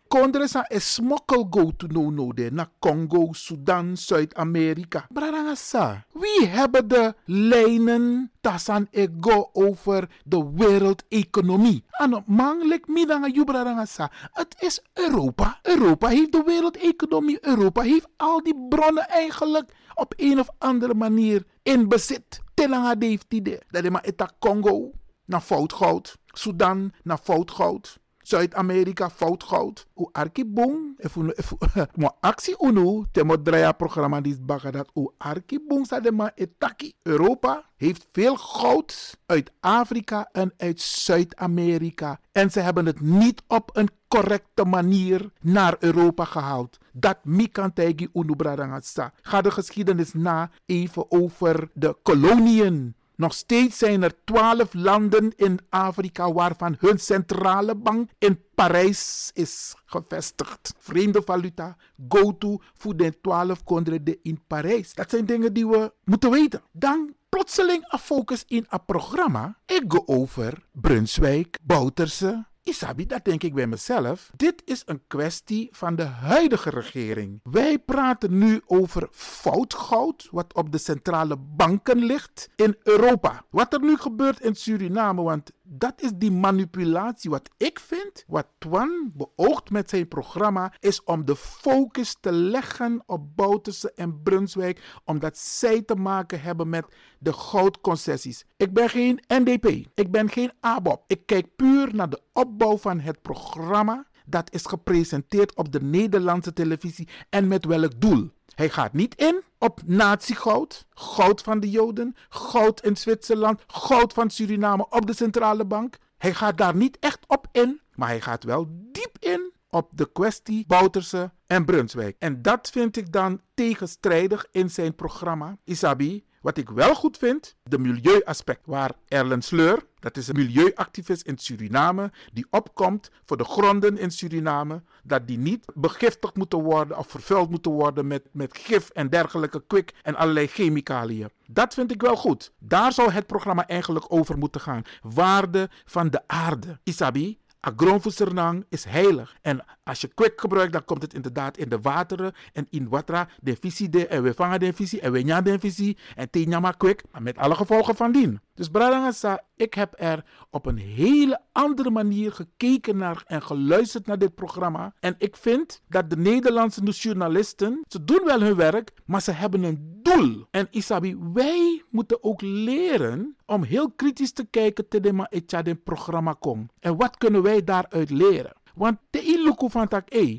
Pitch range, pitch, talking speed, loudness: 165-235 Hz, 195 Hz, 150 wpm, -23 LUFS